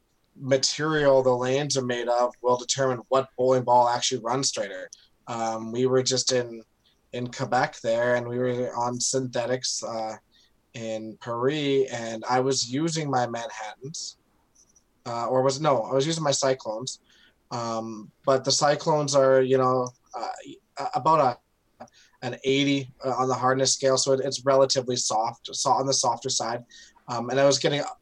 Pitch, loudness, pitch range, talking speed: 130 Hz, -25 LUFS, 120-135 Hz, 165 wpm